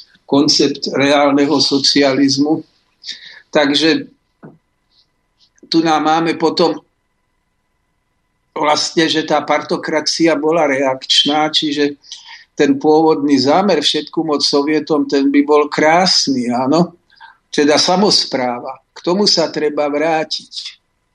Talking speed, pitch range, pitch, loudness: 95 wpm, 145-160 Hz, 150 Hz, -14 LUFS